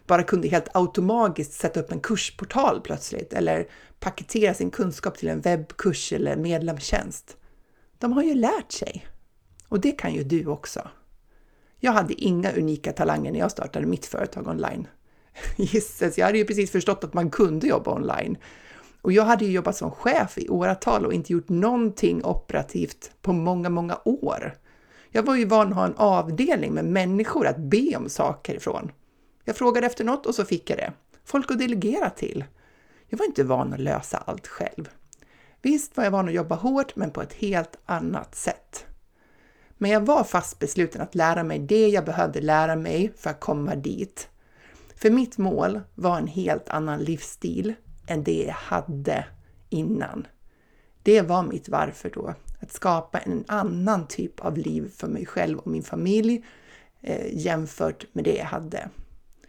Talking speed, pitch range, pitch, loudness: 175 wpm, 170-220 Hz, 195 Hz, -25 LUFS